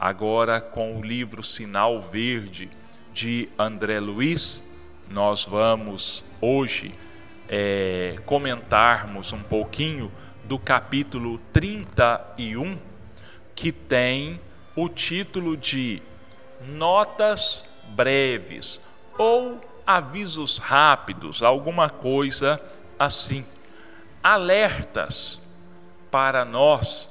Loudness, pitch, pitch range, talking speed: -23 LUFS, 115 Hz, 105-135 Hz, 75 wpm